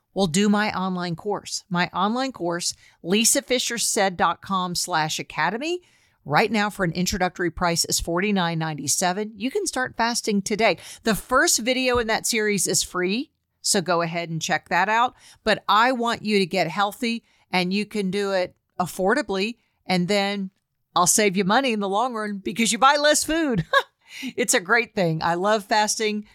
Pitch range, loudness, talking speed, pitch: 180-230 Hz, -22 LUFS, 170 wpm, 205 Hz